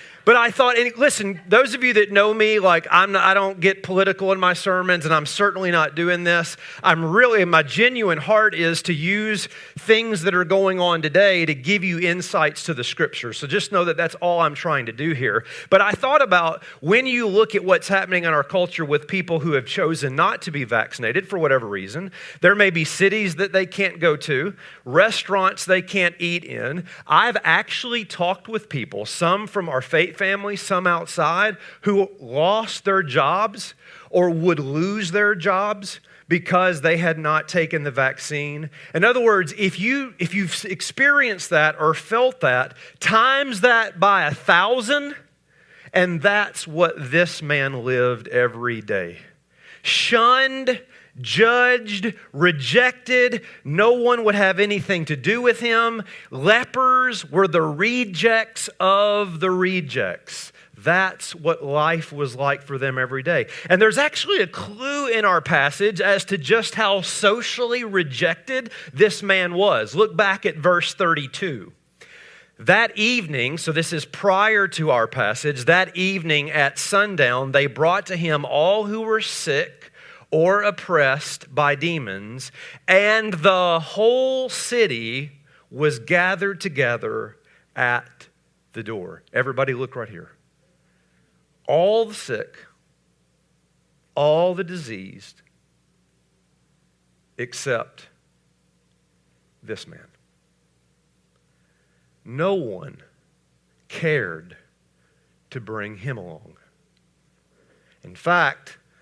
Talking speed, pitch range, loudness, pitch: 140 wpm, 150-210 Hz, -19 LUFS, 180 Hz